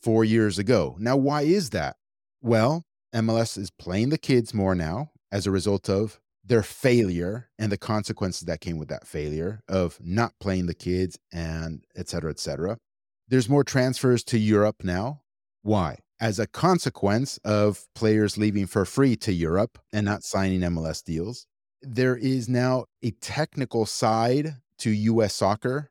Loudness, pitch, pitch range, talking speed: -25 LUFS, 105 Hz, 95-125 Hz, 160 wpm